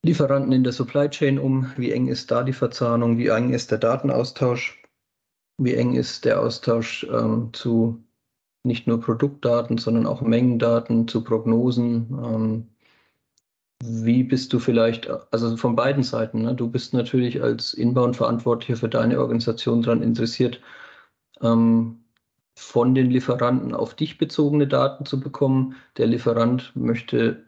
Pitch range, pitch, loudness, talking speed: 115-130 Hz, 120 Hz, -22 LUFS, 140 wpm